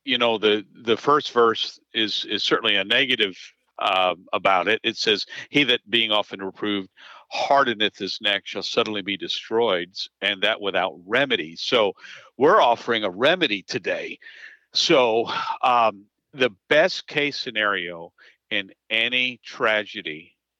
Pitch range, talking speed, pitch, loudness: 100-145 Hz, 135 wpm, 115 Hz, -22 LUFS